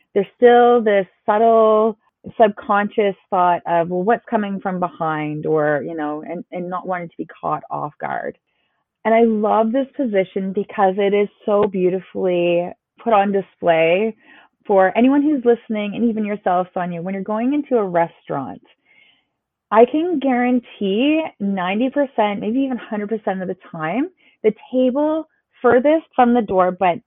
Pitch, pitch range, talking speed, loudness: 210 Hz, 185-240 Hz, 150 wpm, -18 LUFS